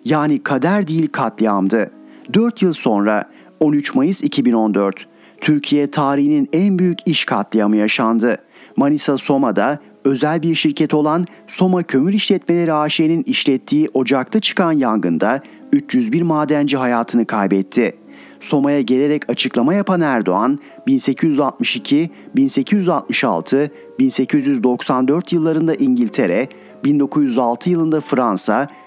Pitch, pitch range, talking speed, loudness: 155 Hz, 135-200 Hz, 100 wpm, -16 LUFS